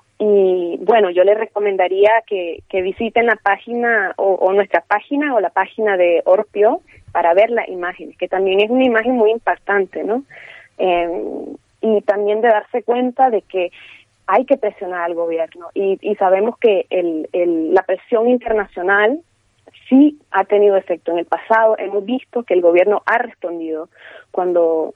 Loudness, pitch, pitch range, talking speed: -16 LUFS, 205 Hz, 180-225 Hz, 165 wpm